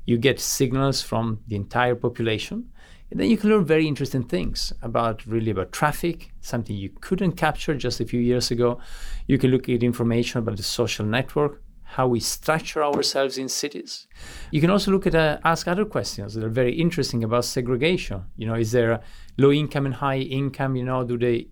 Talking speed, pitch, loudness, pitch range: 200 wpm, 130 Hz, -23 LUFS, 115-150 Hz